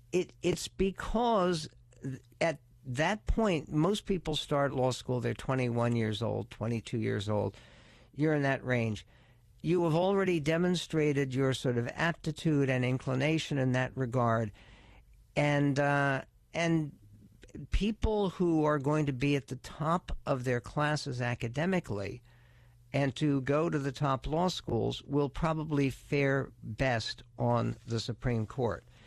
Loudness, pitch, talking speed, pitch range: -32 LUFS, 135 Hz, 140 wpm, 120-155 Hz